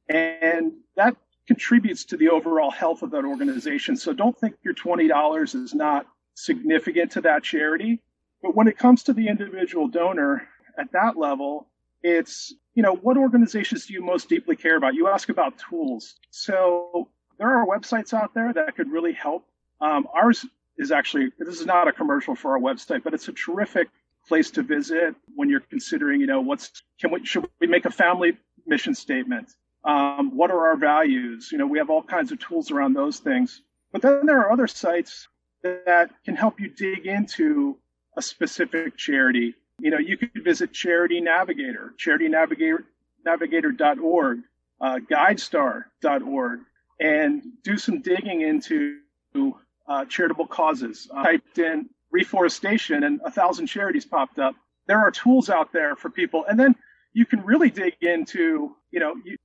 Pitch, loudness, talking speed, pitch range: 250 Hz, -22 LUFS, 170 wpm, 175-295 Hz